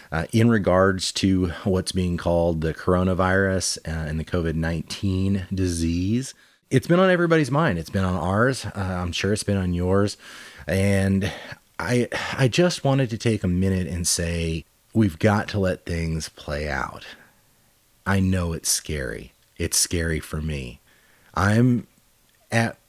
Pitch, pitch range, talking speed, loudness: 95 Hz, 85-110 Hz, 155 wpm, -23 LUFS